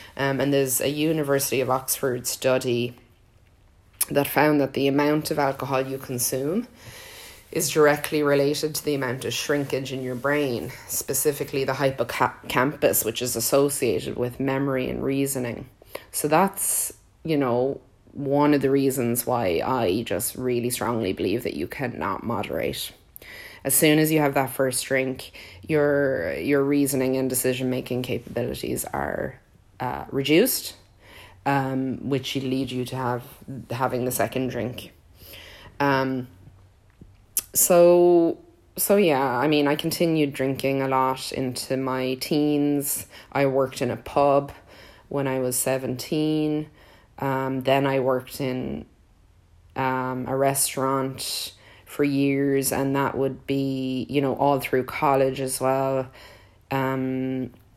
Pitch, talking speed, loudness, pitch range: 130 Hz, 135 wpm, -24 LUFS, 125-140 Hz